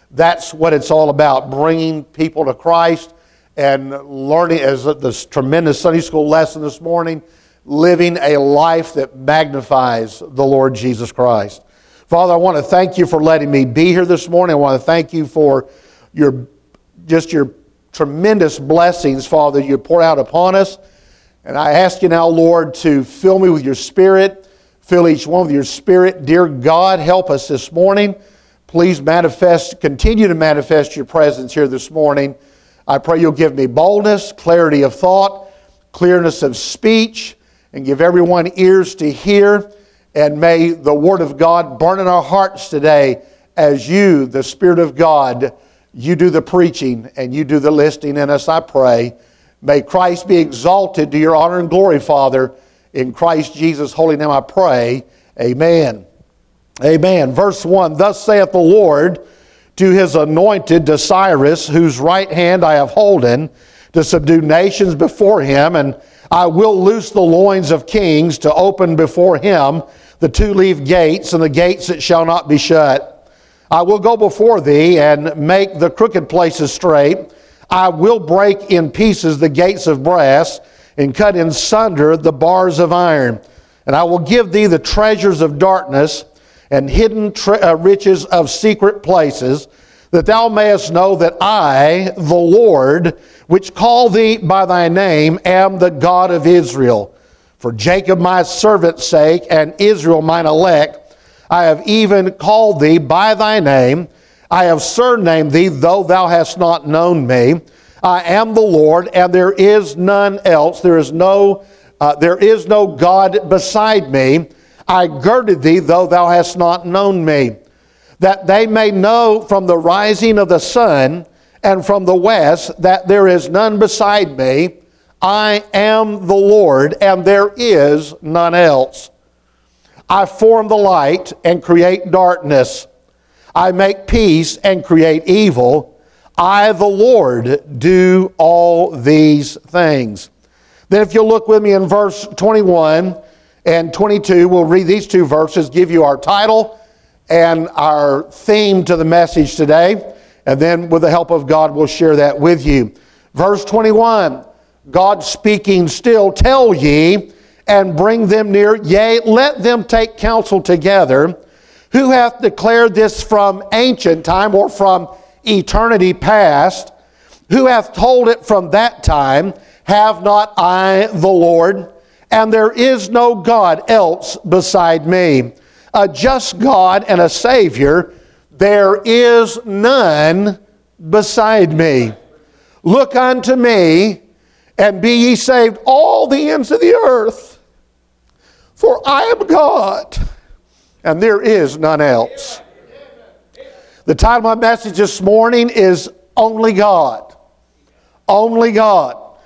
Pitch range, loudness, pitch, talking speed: 155-200 Hz, -11 LUFS, 175 Hz, 150 wpm